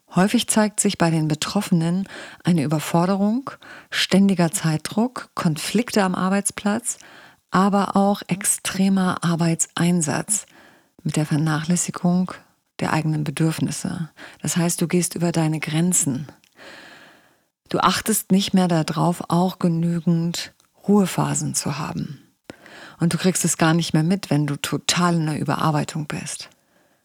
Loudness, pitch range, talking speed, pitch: -21 LUFS, 160-195 Hz, 120 wpm, 175 Hz